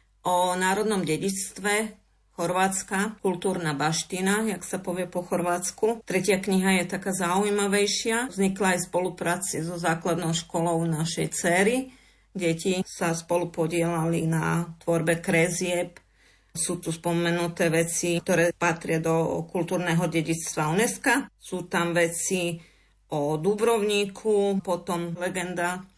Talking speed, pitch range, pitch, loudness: 110 wpm, 170-195 Hz, 180 Hz, -26 LUFS